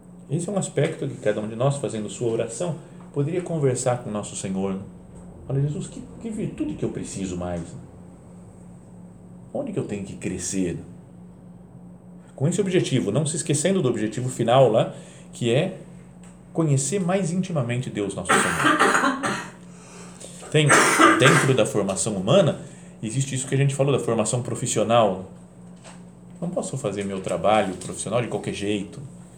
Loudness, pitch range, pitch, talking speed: -23 LUFS, 100-170 Hz, 130 Hz, 150 wpm